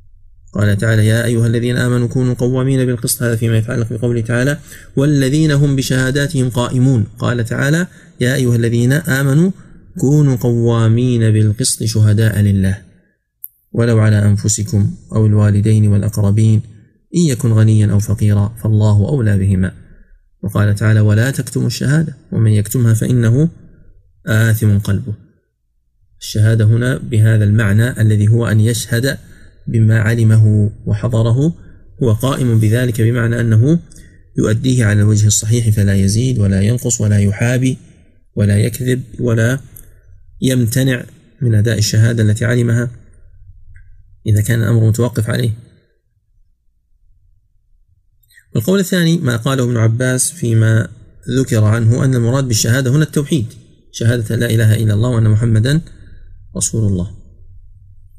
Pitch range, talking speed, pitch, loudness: 105-125 Hz, 120 wpm, 115 Hz, -14 LUFS